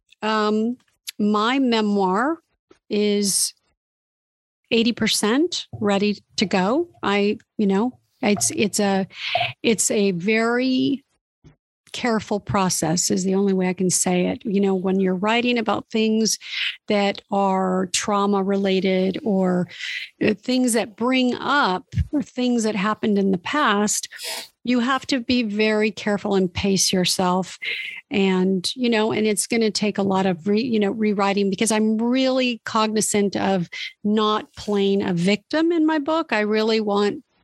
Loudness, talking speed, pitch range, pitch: -21 LUFS, 145 wpm, 195-235 Hz, 210 Hz